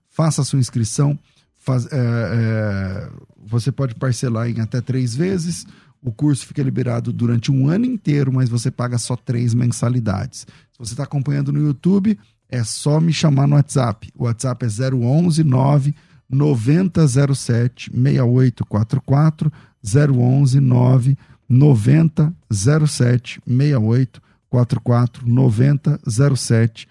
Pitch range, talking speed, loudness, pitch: 120-145 Hz, 120 wpm, -18 LUFS, 130 Hz